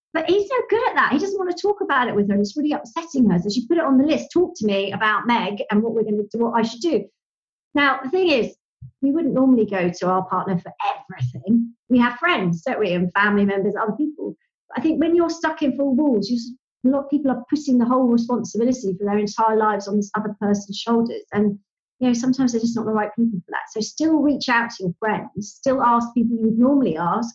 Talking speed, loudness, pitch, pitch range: 260 wpm, -21 LUFS, 235 Hz, 210-275 Hz